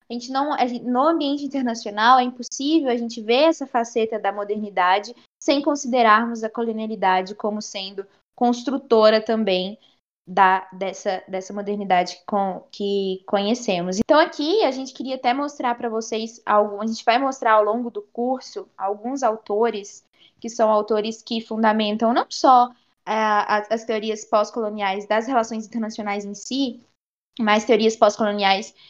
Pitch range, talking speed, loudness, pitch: 205-245 Hz, 145 wpm, -21 LUFS, 225 Hz